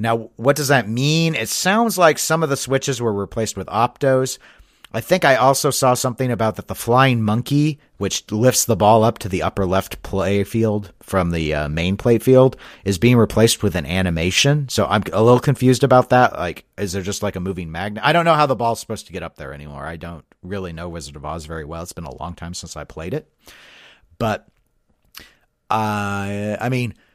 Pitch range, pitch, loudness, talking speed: 95-130 Hz, 110 Hz, -18 LUFS, 220 wpm